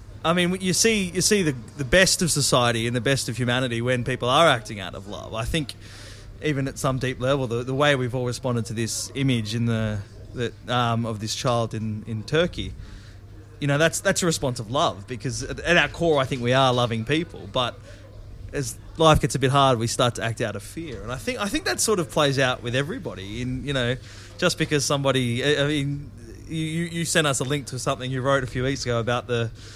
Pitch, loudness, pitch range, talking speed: 125 Hz, -23 LUFS, 115-145 Hz, 240 wpm